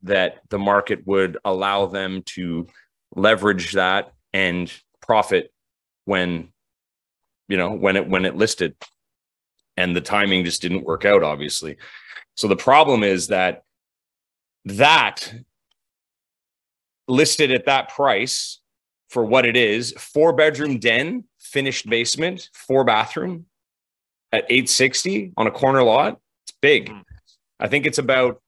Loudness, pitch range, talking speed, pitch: -19 LUFS, 90-130 Hz, 125 wpm, 100 Hz